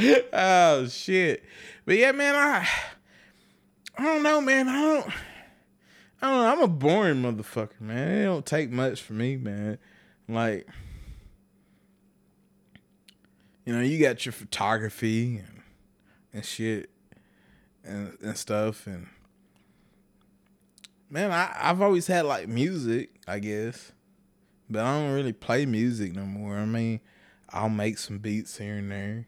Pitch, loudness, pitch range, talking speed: 115 Hz, -26 LUFS, 105-170 Hz, 135 wpm